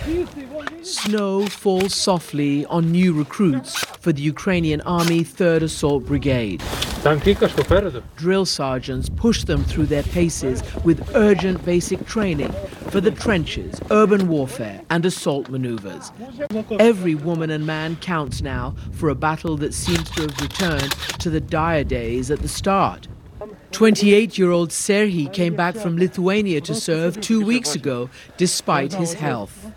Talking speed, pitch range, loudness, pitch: 135 wpm, 150-200 Hz, -20 LUFS, 170 Hz